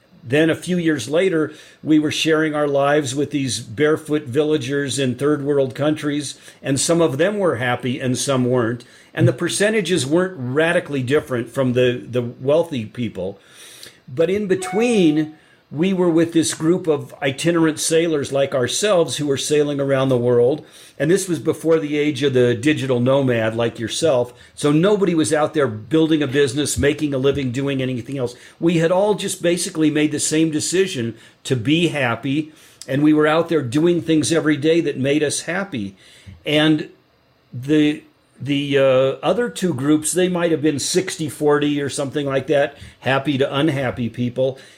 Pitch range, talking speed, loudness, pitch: 135-160 Hz, 170 wpm, -19 LUFS, 150 Hz